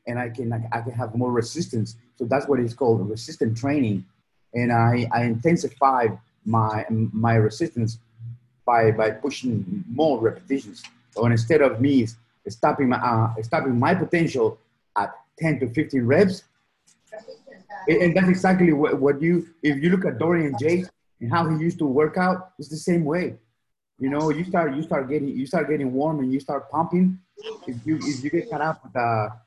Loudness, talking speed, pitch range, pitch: -23 LUFS, 185 wpm, 120-165 Hz, 135 Hz